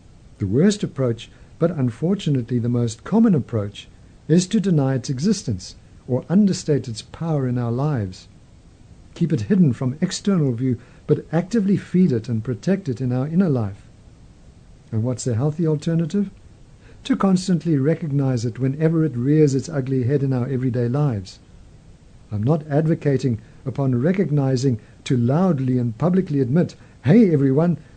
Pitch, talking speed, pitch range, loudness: 135 Hz, 150 wpm, 120-165 Hz, -21 LUFS